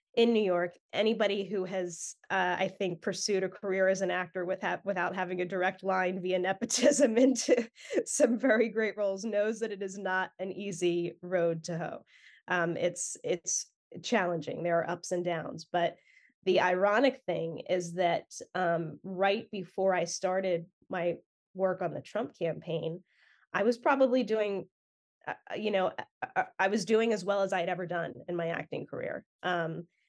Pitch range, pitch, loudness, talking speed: 175-210 Hz, 185 Hz, -31 LUFS, 175 wpm